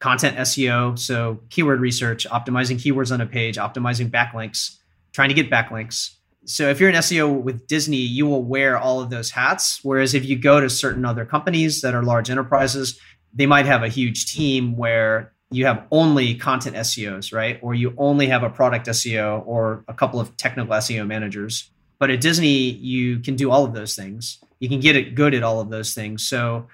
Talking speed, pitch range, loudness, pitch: 200 wpm, 115-135 Hz, -20 LUFS, 125 Hz